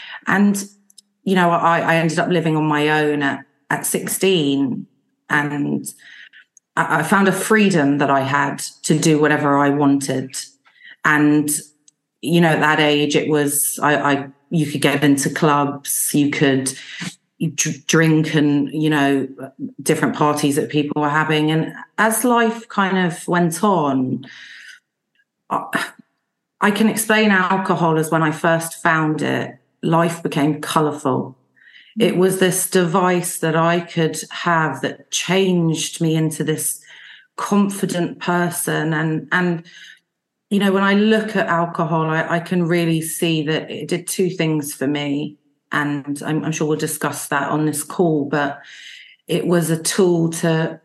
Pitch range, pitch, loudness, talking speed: 150-175 Hz, 160 Hz, -18 LUFS, 150 wpm